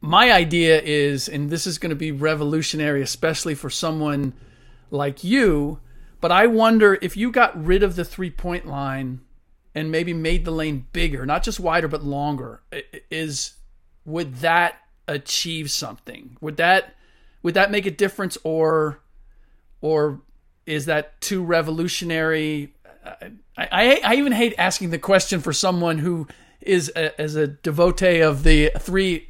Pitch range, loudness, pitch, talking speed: 145-180 Hz, -20 LUFS, 160 Hz, 150 wpm